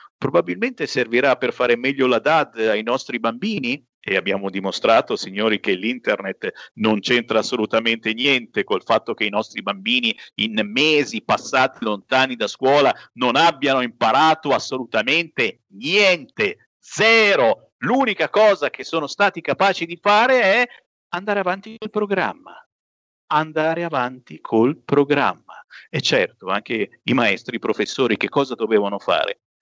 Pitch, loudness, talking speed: 145 Hz, -19 LUFS, 135 wpm